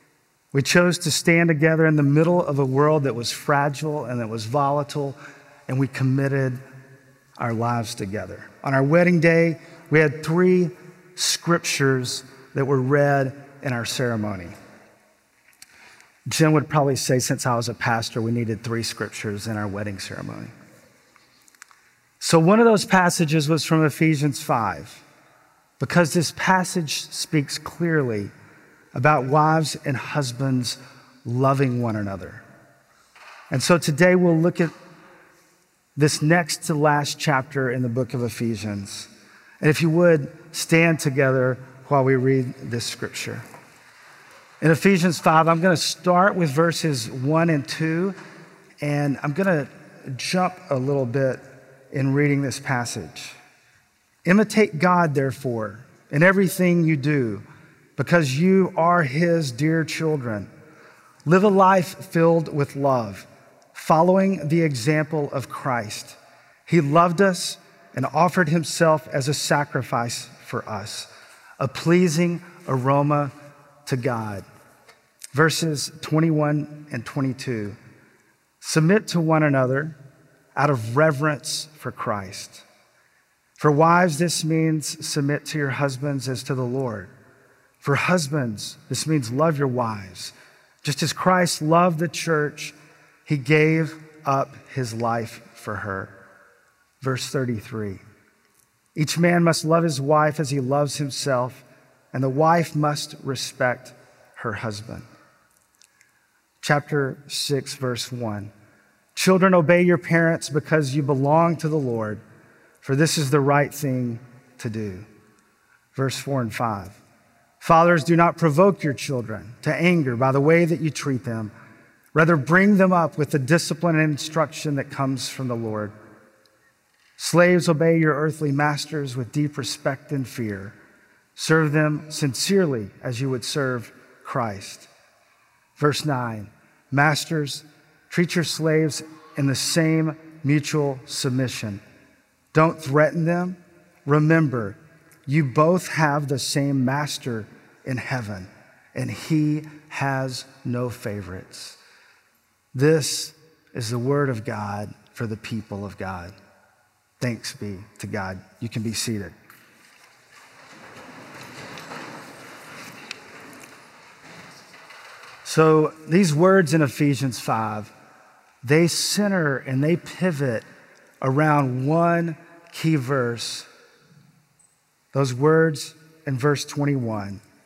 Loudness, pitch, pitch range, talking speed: -22 LUFS, 145 Hz, 125-160 Hz, 125 wpm